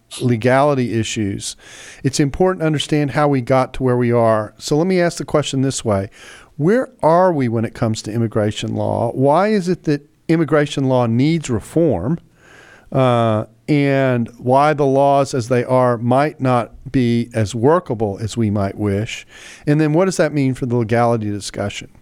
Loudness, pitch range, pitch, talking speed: -17 LUFS, 115-150 Hz, 130 Hz, 175 wpm